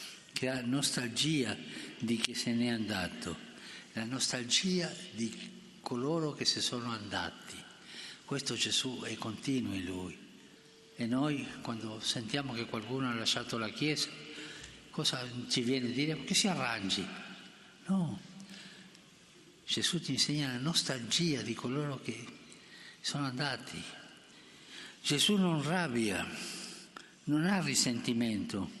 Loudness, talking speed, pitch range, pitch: -34 LUFS, 120 wpm, 115-160 Hz, 130 Hz